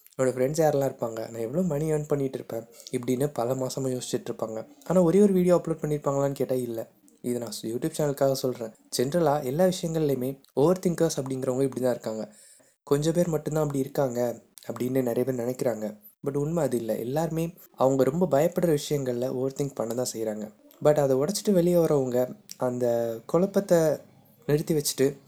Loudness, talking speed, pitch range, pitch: -26 LUFS, 165 wpm, 125-155 Hz, 135 Hz